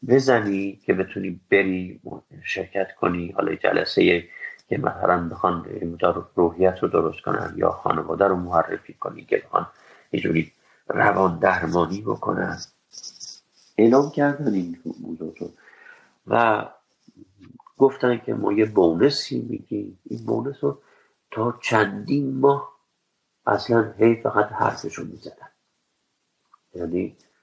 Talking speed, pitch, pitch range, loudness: 110 wpm, 100 Hz, 90-125 Hz, -23 LUFS